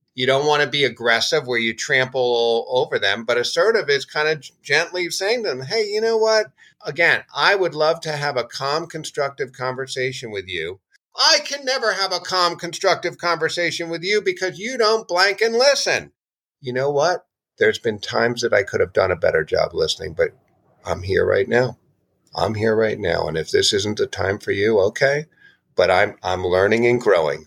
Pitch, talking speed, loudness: 175 Hz, 200 wpm, -19 LUFS